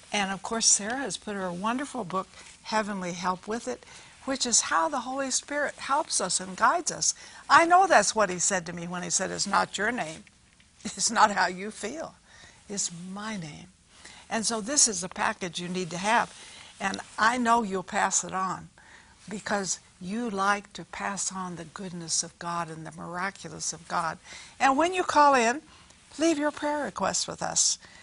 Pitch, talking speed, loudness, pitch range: 205 Hz, 195 wpm, -26 LUFS, 185-240 Hz